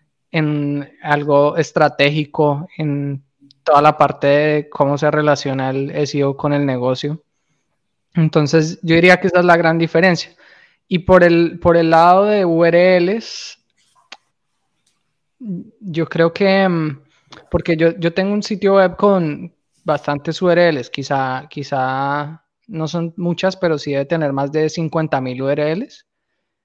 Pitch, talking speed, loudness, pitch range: 160 Hz, 135 wpm, -16 LUFS, 145-175 Hz